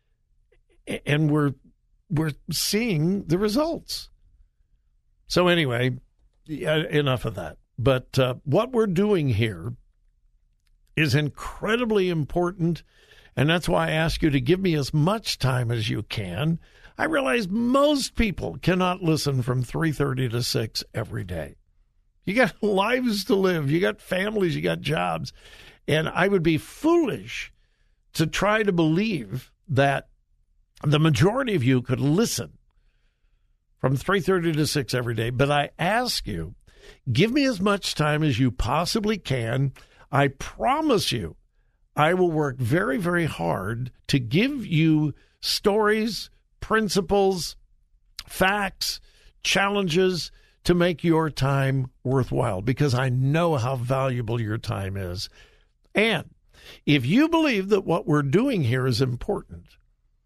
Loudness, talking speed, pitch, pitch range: -24 LUFS, 130 wpm, 150 Hz, 125-185 Hz